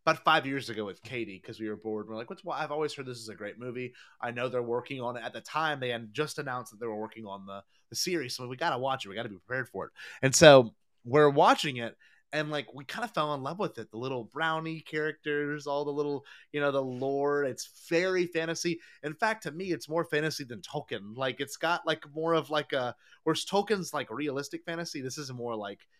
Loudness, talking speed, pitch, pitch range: -30 LUFS, 260 wpm, 145 Hz, 120-160 Hz